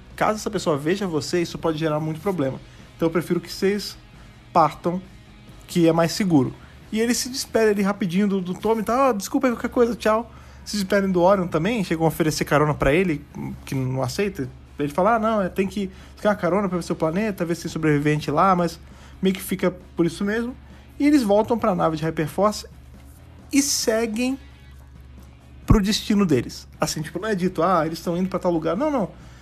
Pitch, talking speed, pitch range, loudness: 180 Hz, 205 wpm, 155-210 Hz, -22 LUFS